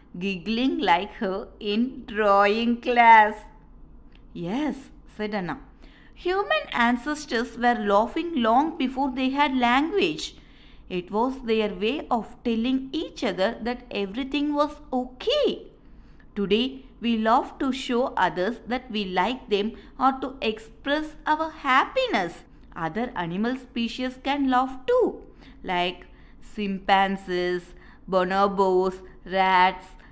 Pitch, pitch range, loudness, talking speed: 240 Hz, 205-270 Hz, -24 LUFS, 110 wpm